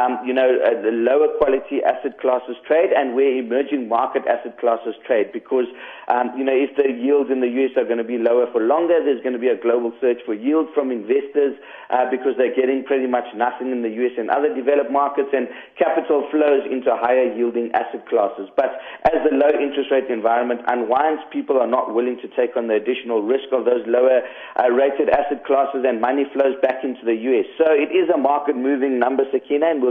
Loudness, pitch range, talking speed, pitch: -19 LUFS, 125-140 Hz, 220 wpm, 130 Hz